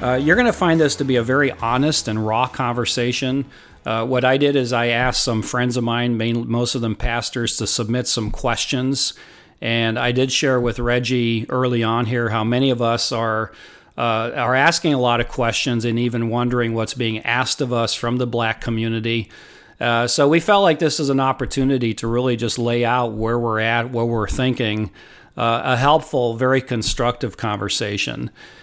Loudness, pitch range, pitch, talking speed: -19 LUFS, 115-130 Hz, 120 Hz, 195 wpm